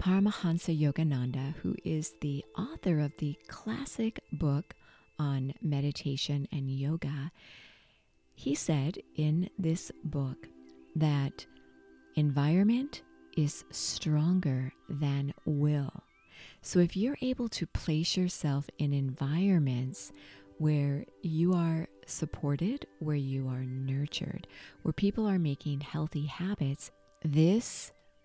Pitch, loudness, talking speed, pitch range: 150 Hz, -32 LUFS, 105 wpm, 135-170 Hz